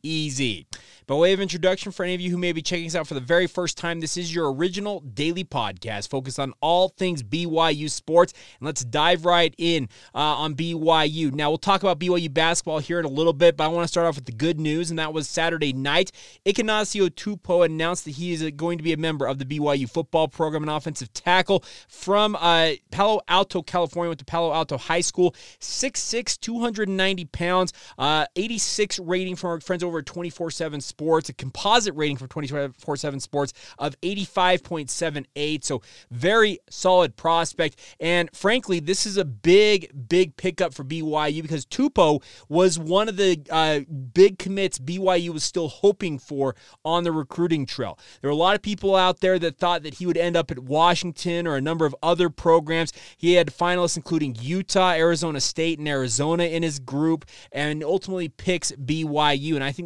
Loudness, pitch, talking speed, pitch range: -23 LUFS, 165 Hz, 190 wpm, 150-180 Hz